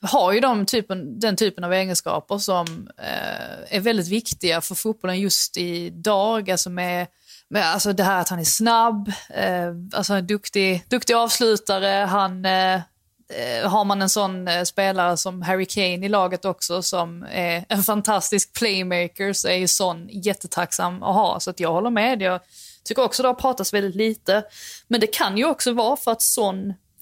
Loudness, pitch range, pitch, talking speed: -21 LUFS, 180-215 Hz, 195 Hz, 180 wpm